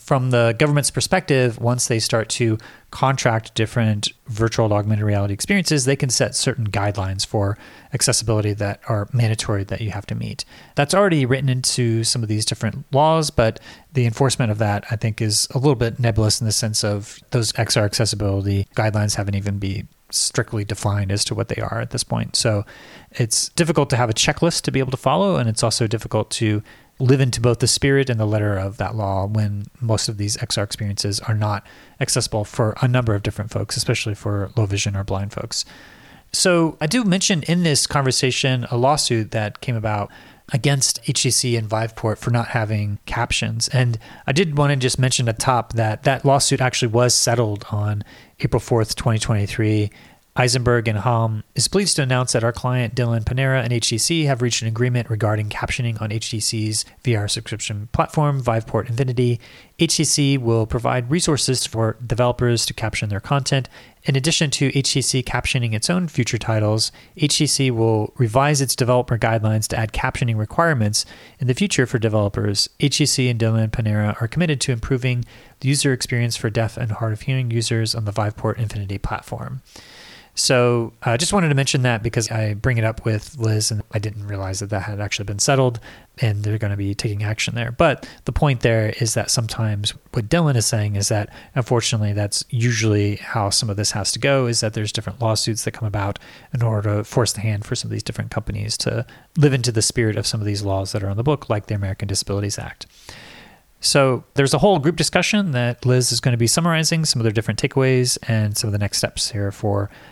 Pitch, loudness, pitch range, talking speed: 115 Hz, -20 LUFS, 110-130 Hz, 200 wpm